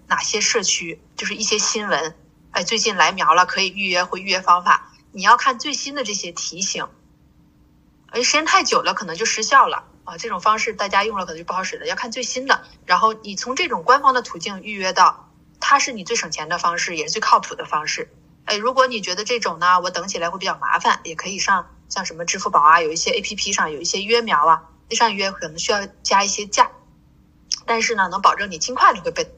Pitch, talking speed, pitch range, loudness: 210 Hz, 335 characters per minute, 180-250 Hz, -19 LUFS